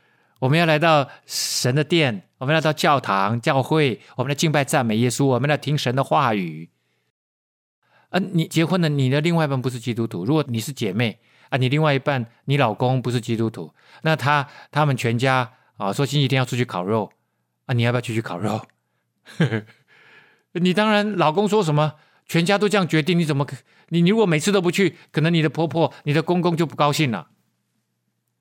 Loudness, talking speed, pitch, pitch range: -21 LUFS, 285 characters per minute, 145 Hz, 125-165 Hz